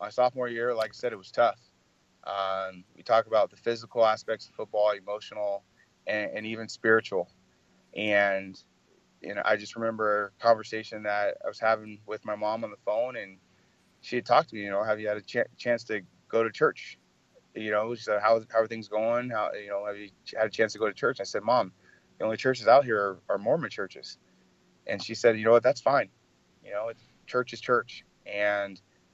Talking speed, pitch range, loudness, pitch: 225 wpm, 105-115 Hz, -28 LUFS, 110 Hz